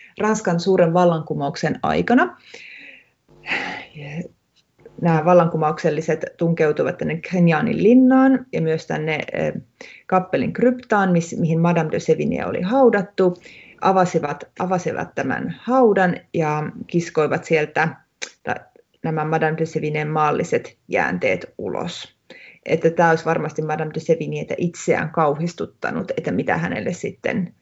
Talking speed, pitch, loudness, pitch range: 105 wpm, 165 Hz, -20 LUFS, 155-185 Hz